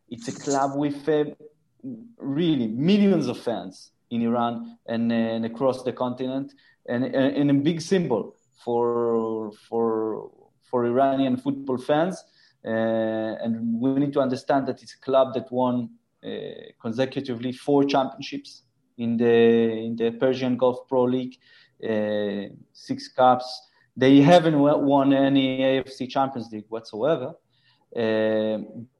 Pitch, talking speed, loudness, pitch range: 130 Hz, 130 wpm, -23 LUFS, 115-140 Hz